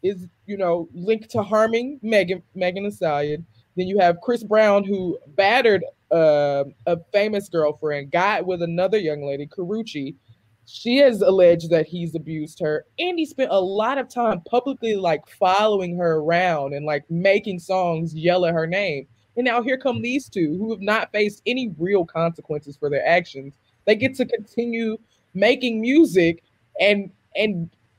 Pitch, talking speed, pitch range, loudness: 185 Hz, 165 wpm, 160-215 Hz, -21 LUFS